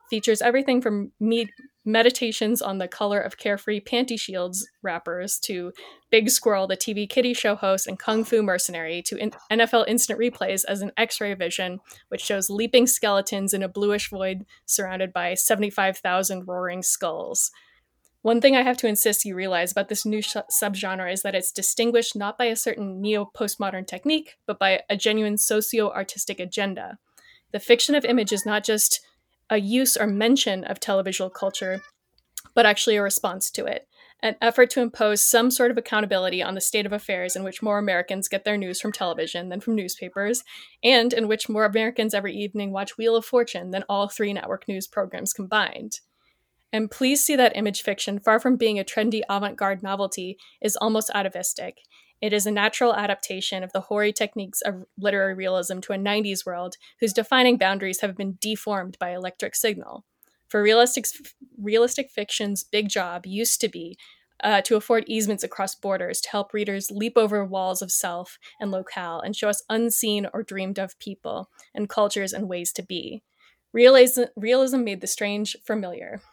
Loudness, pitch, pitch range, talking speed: -23 LUFS, 210 Hz, 195-225 Hz, 180 wpm